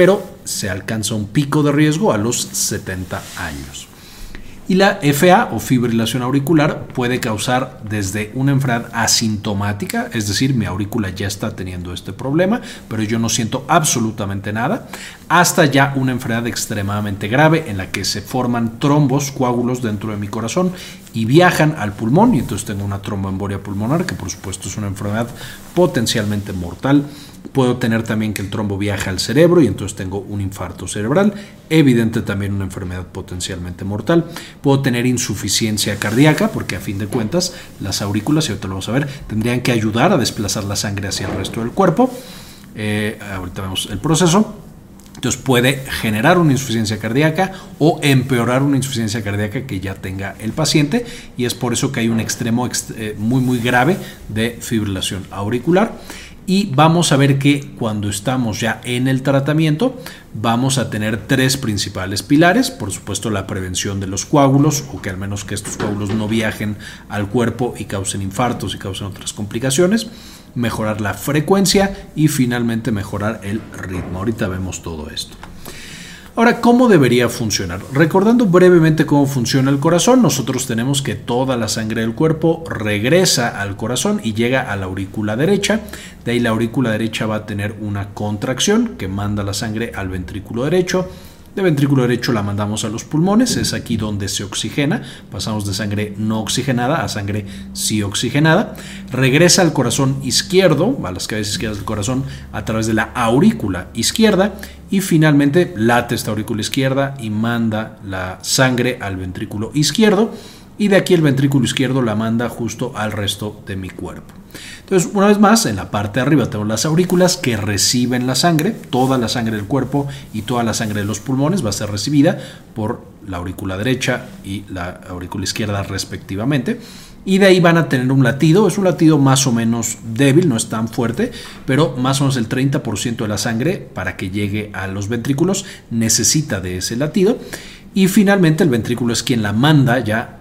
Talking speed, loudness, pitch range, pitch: 175 wpm, -17 LUFS, 105-145 Hz, 115 Hz